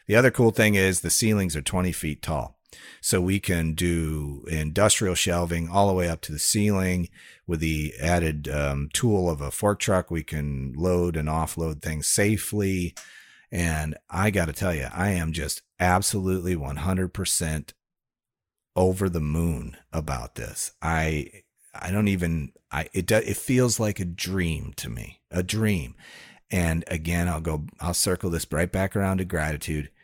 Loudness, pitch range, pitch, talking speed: -25 LUFS, 80-95 Hz, 90 Hz, 170 wpm